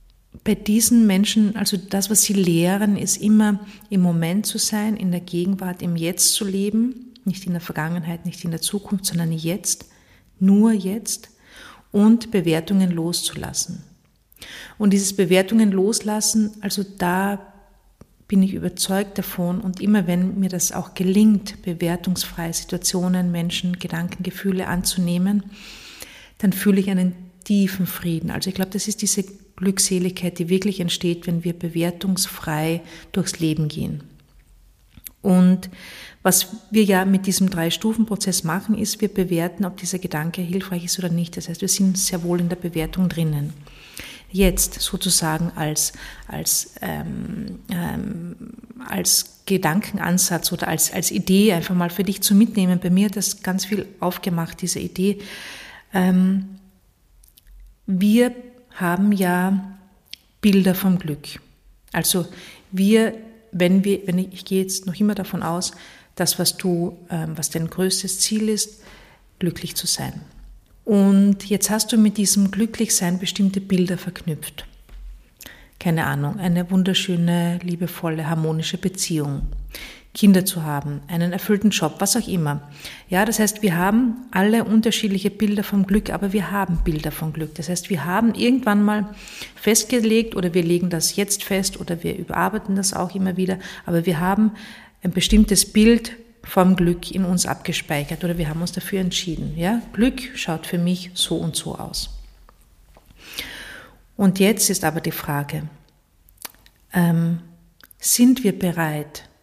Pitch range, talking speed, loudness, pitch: 175-200 Hz, 145 wpm, -20 LUFS, 185 Hz